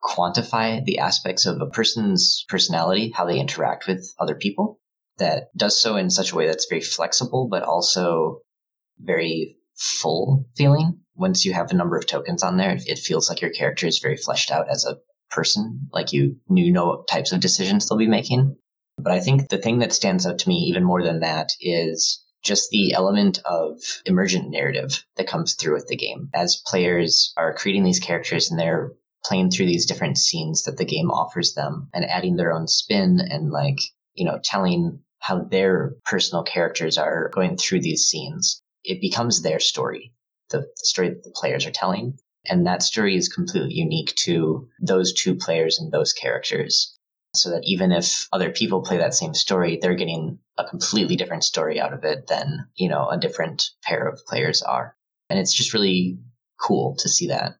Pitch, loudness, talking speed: 145 Hz, -21 LUFS, 190 wpm